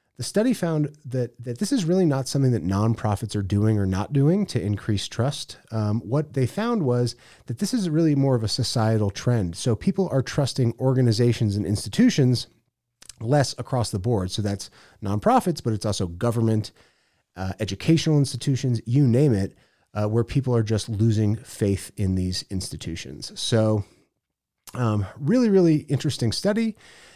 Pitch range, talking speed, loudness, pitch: 105-140 Hz, 165 wpm, -23 LUFS, 120 Hz